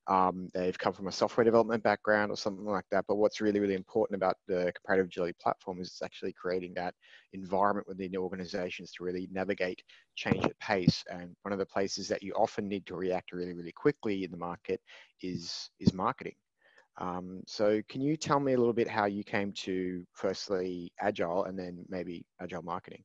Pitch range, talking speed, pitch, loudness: 90-105 Hz, 200 wpm, 95 Hz, -33 LUFS